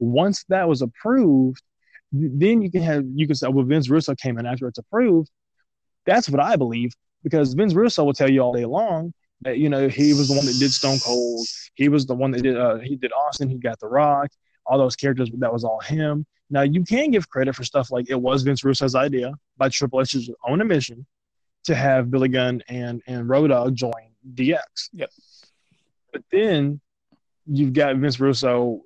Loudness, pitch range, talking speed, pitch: -21 LUFS, 125-150 Hz, 205 wpm, 135 Hz